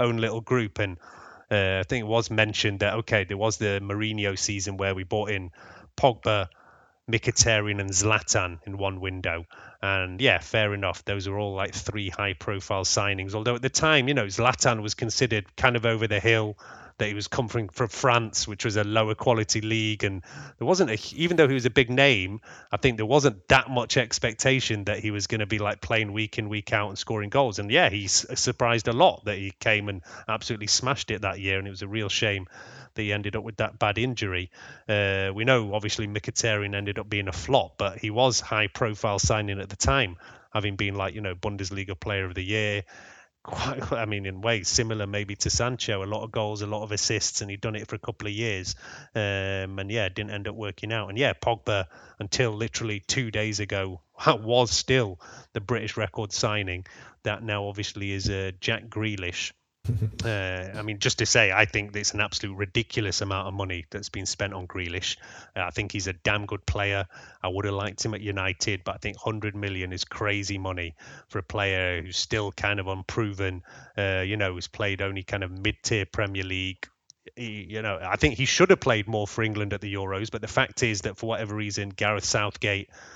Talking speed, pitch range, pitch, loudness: 215 wpm, 100-115 Hz, 105 Hz, -26 LUFS